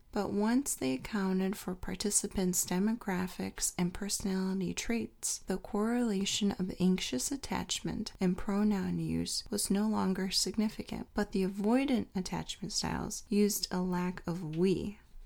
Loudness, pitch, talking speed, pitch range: -33 LUFS, 195 Hz, 125 wpm, 185-210 Hz